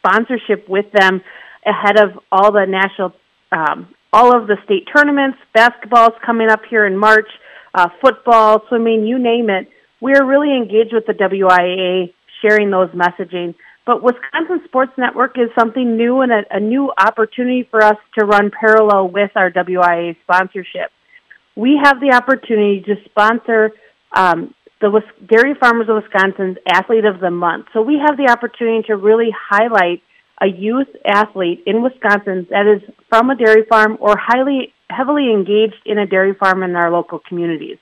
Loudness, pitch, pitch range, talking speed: -13 LUFS, 215 Hz, 195-240 Hz, 165 wpm